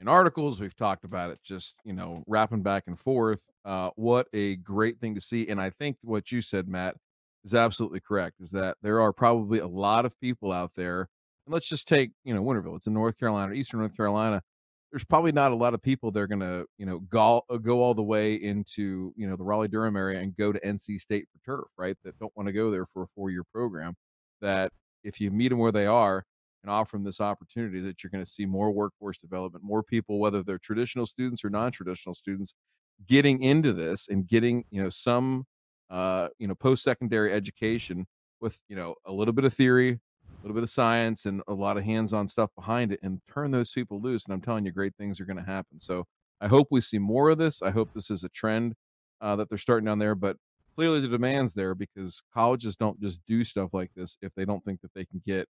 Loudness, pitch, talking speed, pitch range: -28 LUFS, 105 Hz, 230 wpm, 95-115 Hz